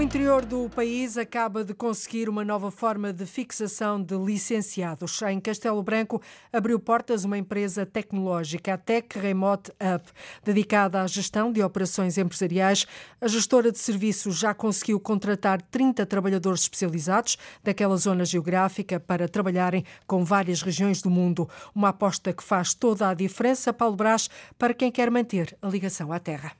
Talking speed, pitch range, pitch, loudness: 155 wpm, 190-225 Hz, 200 Hz, -25 LUFS